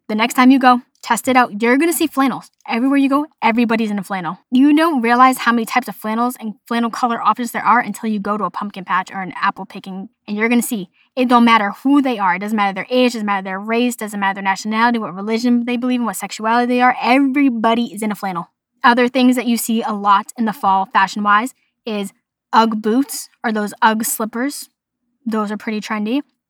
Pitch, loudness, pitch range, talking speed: 230 Hz, -16 LUFS, 210-250 Hz, 240 wpm